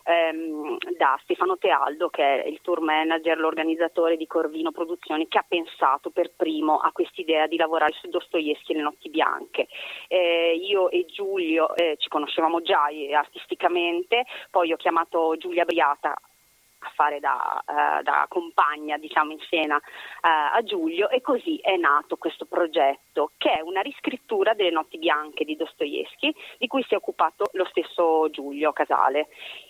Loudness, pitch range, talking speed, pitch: -24 LUFS, 160-235 Hz, 160 wpm, 170 Hz